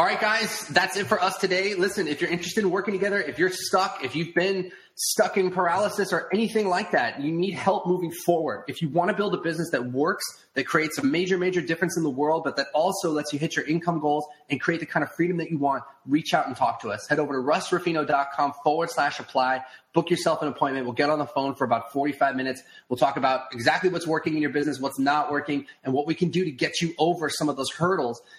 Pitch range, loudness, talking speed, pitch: 145-185 Hz, -25 LUFS, 255 wpm, 160 Hz